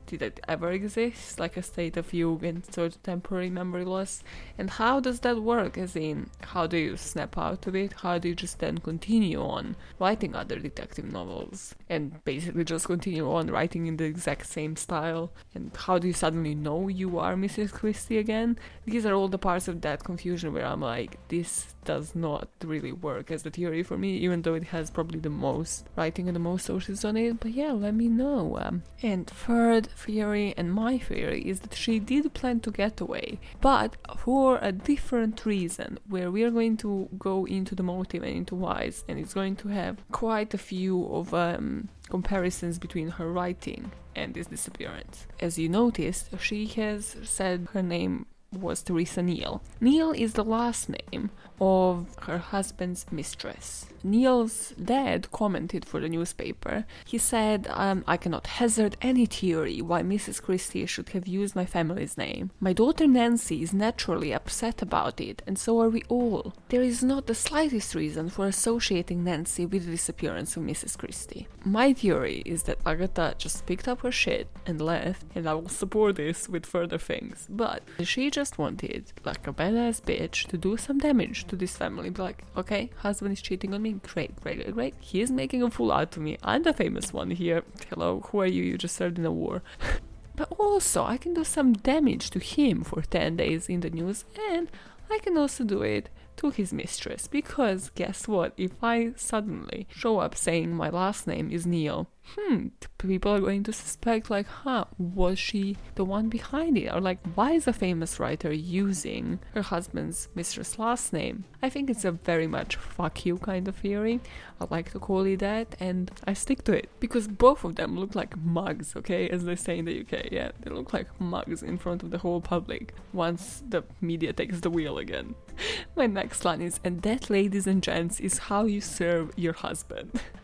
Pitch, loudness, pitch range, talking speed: 190 Hz, -29 LUFS, 175-230 Hz, 195 wpm